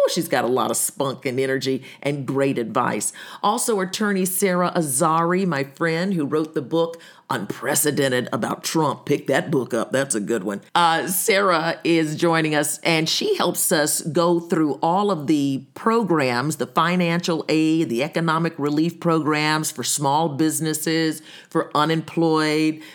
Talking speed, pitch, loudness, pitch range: 155 wpm, 160 Hz, -21 LUFS, 145-170 Hz